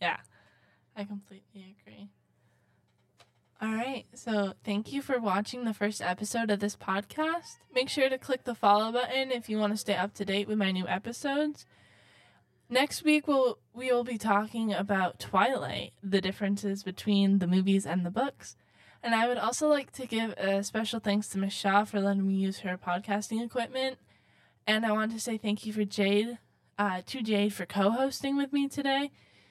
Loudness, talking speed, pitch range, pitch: -30 LUFS, 180 wpm, 195-245 Hz, 210 Hz